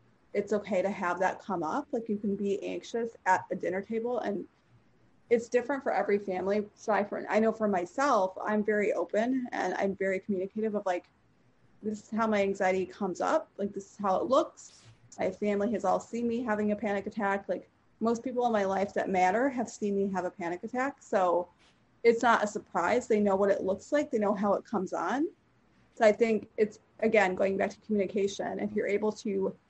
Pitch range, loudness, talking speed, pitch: 195-225 Hz, -30 LUFS, 215 wpm, 205 Hz